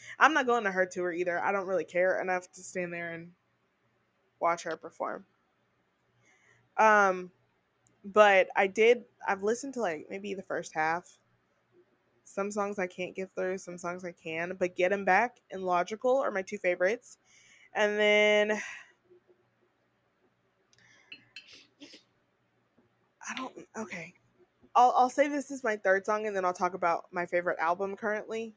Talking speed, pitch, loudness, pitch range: 155 wpm, 190 Hz, -29 LUFS, 180-215 Hz